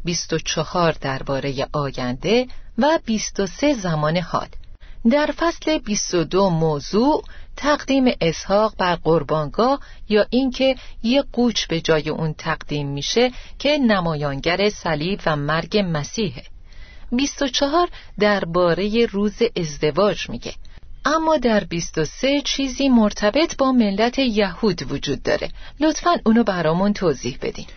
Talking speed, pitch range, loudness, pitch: 110 wpm, 160-260 Hz, -20 LUFS, 205 Hz